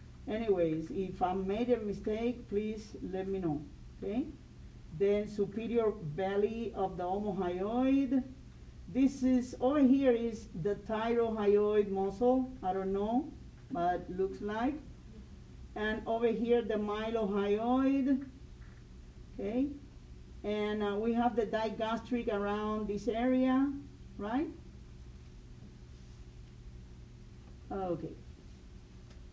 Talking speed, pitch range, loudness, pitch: 100 wpm, 185-235 Hz, -33 LUFS, 210 Hz